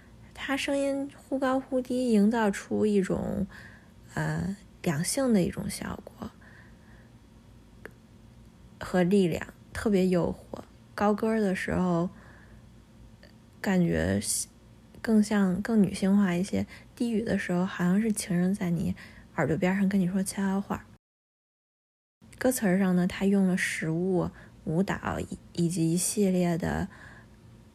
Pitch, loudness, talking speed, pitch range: 185 Hz, -28 LUFS, 175 characters per minute, 165-205 Hz